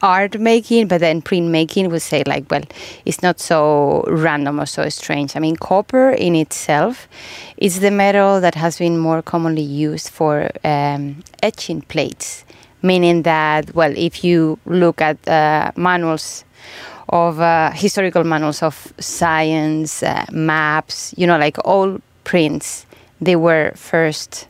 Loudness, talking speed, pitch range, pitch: -16 LUFS, 145 wpm, 155-180 Hz, 165 Hz